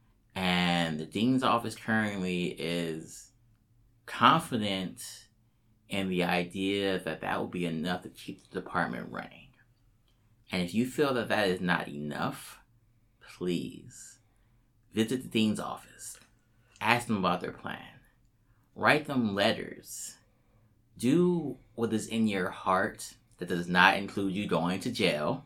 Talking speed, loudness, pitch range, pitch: 130 wpm, -30 LUFS, 90-115 Hz, 110 Hz